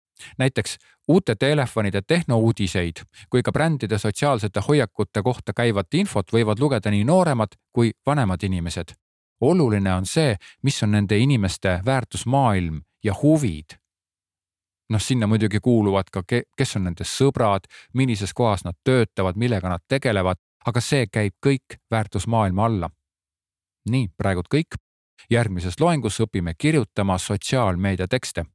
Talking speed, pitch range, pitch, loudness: 125 wpm, 95-130 Hz, 105 Hz, -22 LUFS